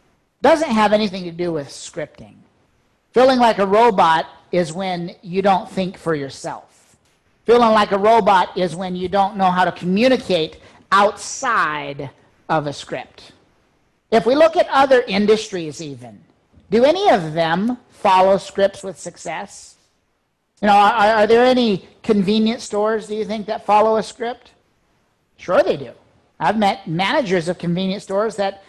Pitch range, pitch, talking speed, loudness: 175-220 Hz, 200 Hz, 155 wpm, -17 LUFS